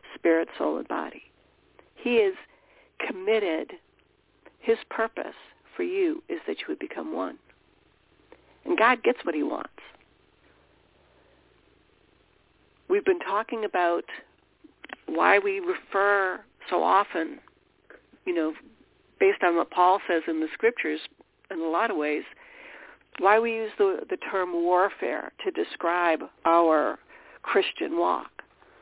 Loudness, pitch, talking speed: -26 LUFS, 230 Hz, 125 wpm